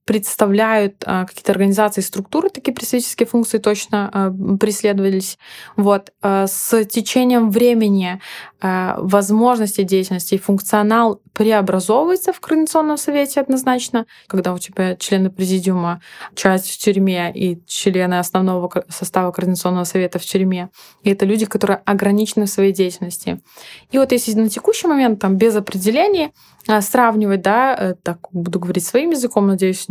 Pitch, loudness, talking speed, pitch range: 200 Hz, -17 LUFS, 125 wpm, 190-230 Hz